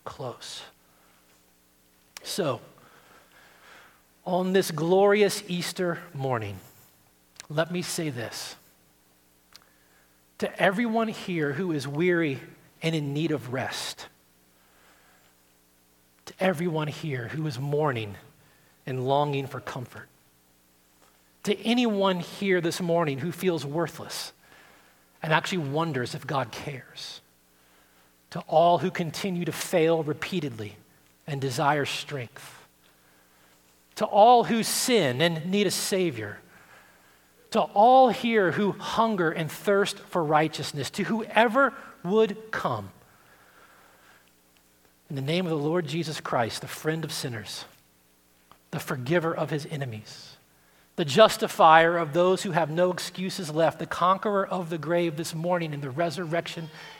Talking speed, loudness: 120 wpm, -26 LUFS